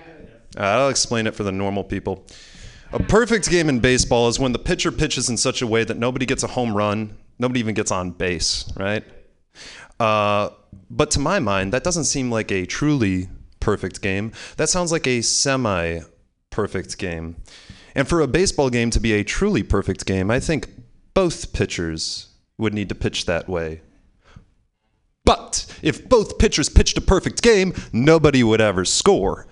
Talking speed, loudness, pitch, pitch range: 175 wpm, -20 LUFS, 110 Hz, 95-130 Hz